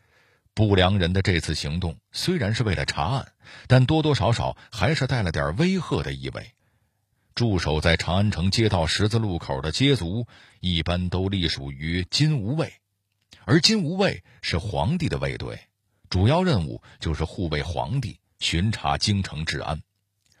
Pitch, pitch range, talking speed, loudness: 100 Hz, 90-120 Hz, 235 characters per minute, -24 LUFS